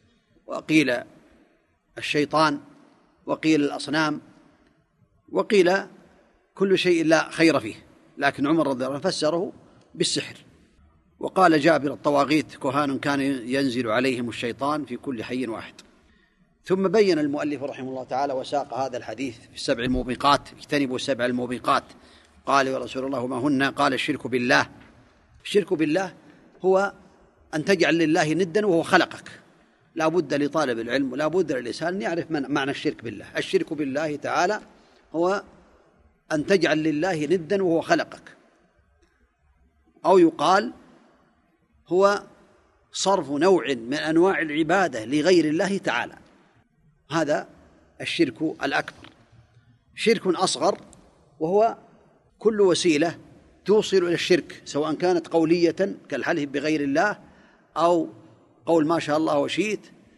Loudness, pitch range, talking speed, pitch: -23 LUFS, 135-190 Hz, 120 wpm, 155 Hz